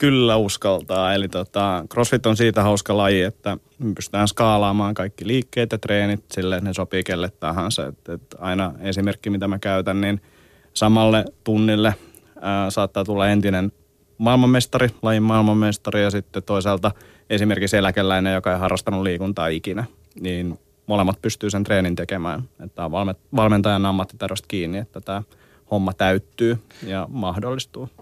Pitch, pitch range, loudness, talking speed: 100 Hz, 95-110 Hz, -21 LUFS, 145 wpm